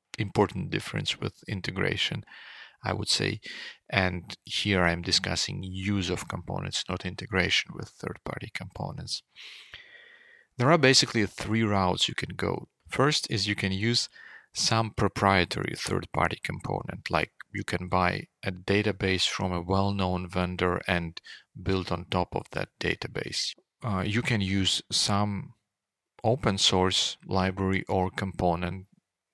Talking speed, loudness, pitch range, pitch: 135 wpm, -28 LUFS, 90-105 Hz, 95 Hz